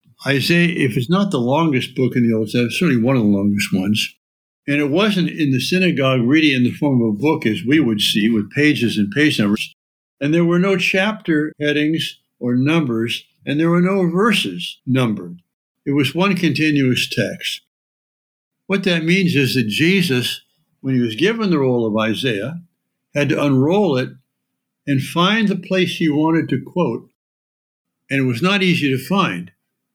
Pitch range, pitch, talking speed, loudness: 120-170 Hz, 145 Hz, 185 wpm, -17 LUFS